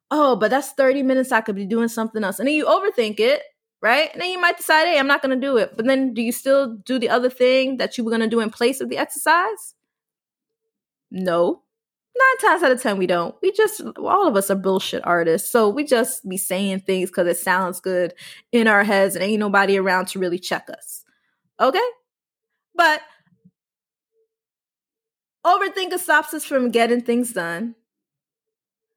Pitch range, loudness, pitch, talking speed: 195-300 Hz, -19 LUFS, 240 Hz, 195 wpm